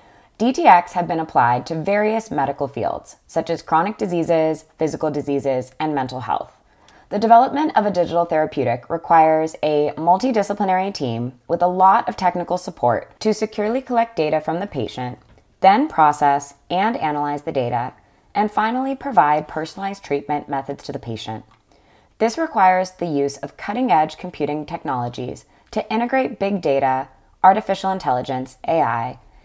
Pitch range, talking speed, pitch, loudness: 140-195 Hz, 145 wpm, 160 Hz, -20 LUFS